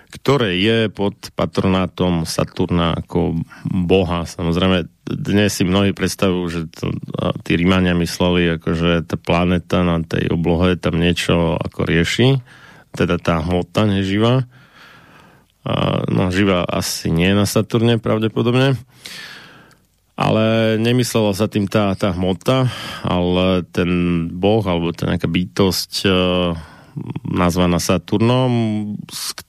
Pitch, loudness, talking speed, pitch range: 95 Hz, -18 LUFS, 120 wpm, 85-105 Hz